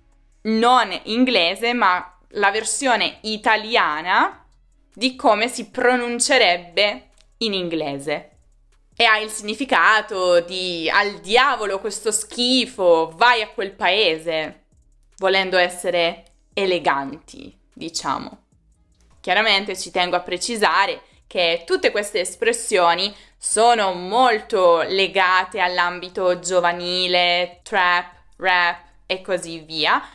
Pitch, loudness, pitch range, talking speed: 190 Hz, -19 LUFS, 175-225 Hz, 95 wpm